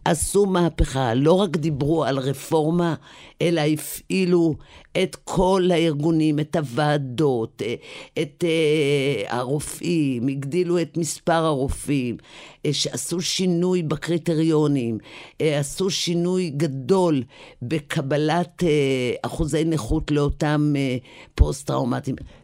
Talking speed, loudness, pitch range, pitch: 85 wpm, -22 LUFS, 140-170 Hz, 155 Hz